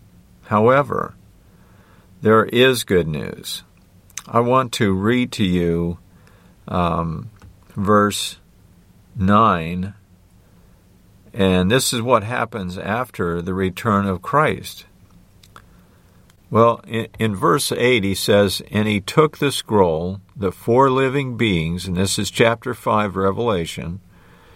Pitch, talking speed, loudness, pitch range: 95 Hz, 110 wpm, -19 LUFS, 90-110 Hz